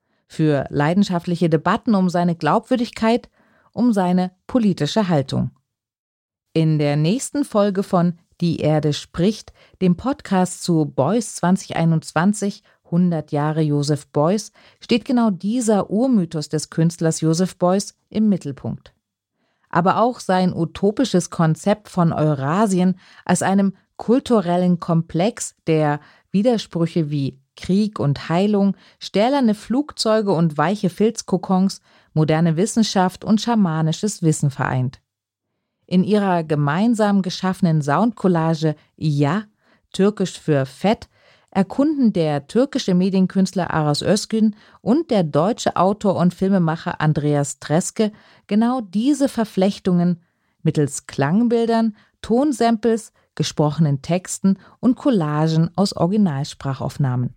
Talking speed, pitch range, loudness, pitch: 105 wpm, 160-210 Hz, -20 LUFS, 185 Hz